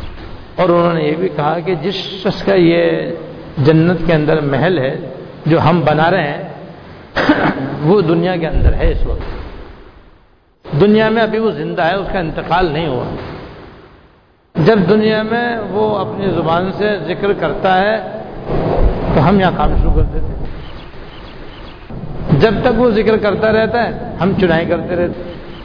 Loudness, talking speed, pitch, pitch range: -14 LUFS, 160 wpm, 180 Hz, 160-205 Hz